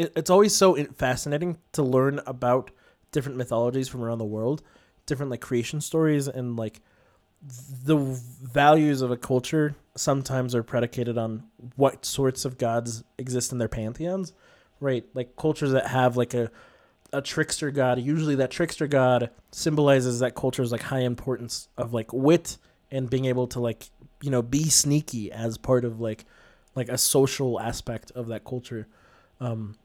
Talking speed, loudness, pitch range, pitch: 160 wpm, -25 LUFS, 120-145 Hz, 130 Hz